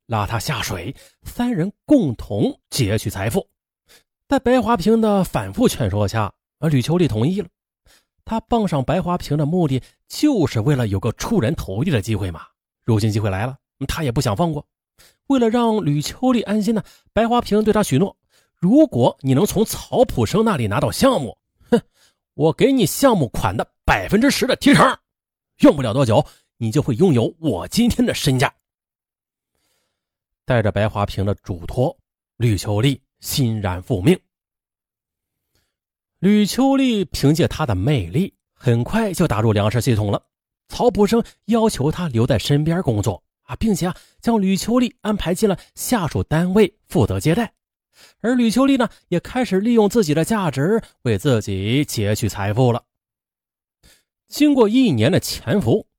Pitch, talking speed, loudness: 160 Hz, 235 characters per minute, -19 LUFS